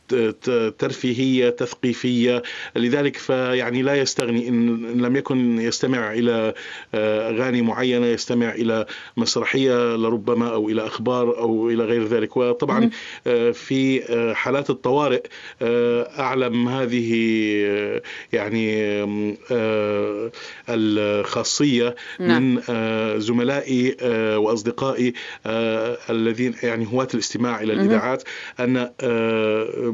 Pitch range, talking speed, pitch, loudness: 110-125 Hz, 85 wpm, 120 Hz, -21 LUFS